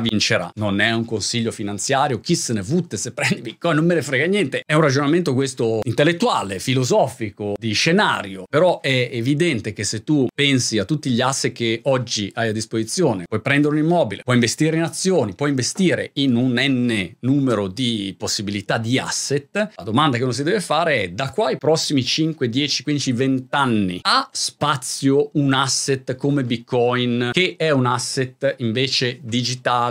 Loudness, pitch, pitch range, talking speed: -20 LUFS, 130 Hz, 115-145 Hz, 180 wpm